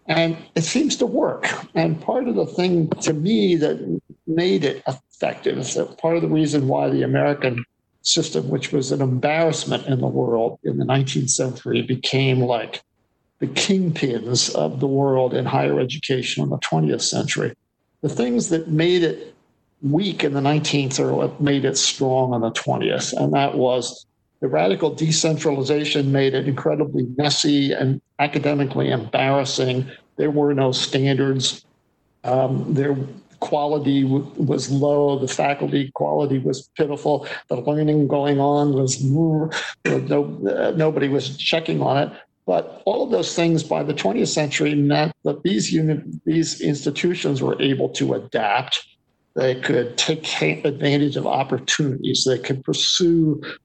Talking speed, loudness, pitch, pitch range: 150 wpm, -20 LUFS, 145 Hz, 130-155 Hz